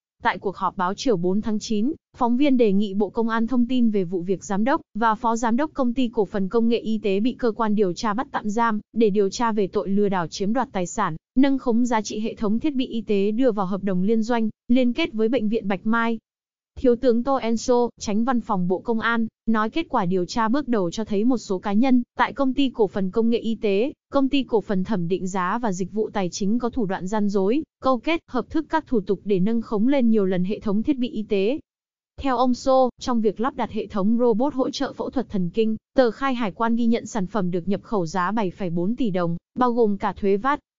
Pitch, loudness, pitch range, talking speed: 225 Hz, -23 LUFS, 205-245 Hz, 265 wpm